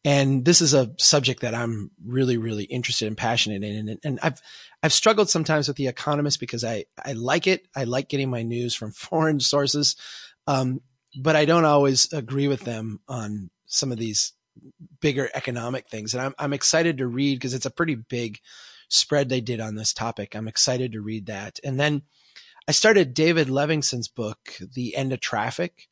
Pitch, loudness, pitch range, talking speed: 130 Hz, -23 LUFS, 115-145 Hz, 190 wpm